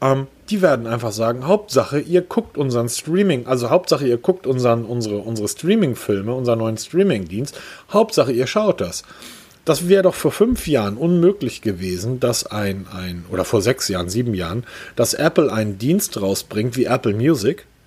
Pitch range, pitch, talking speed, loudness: 110-170 Hz, 125 Hz, 170 wpm, -19 LUFS